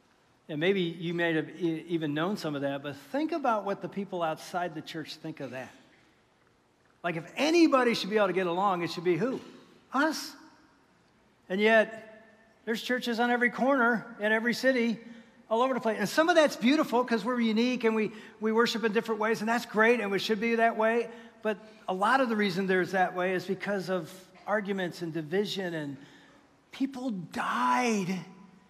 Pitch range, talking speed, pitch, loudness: 180-235 Hz, 190 wpm, 215 Hz, -29 LUFS